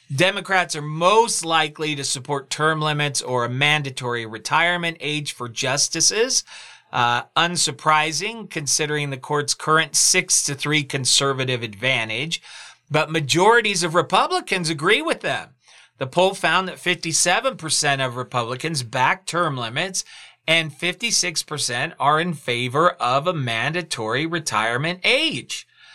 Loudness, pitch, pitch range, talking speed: -20 LUFS, 155 Hz, 135-175 Hz, 125 wpm